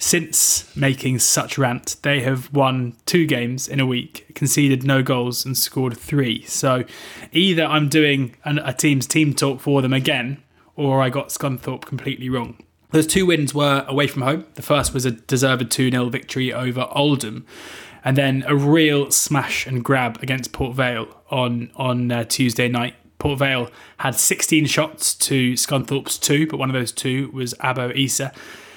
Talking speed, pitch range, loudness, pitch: 170 wpm, 125-145 Hz, -19 LUFS, 135 Hz